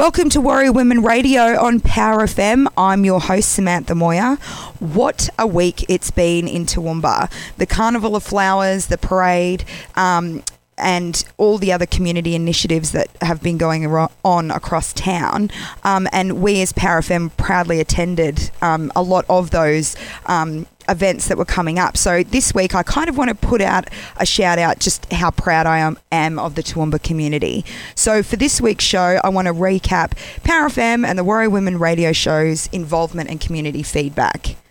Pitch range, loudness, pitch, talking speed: 165-200 Hz, -16 LUFS, 180 Hz, 175 wpm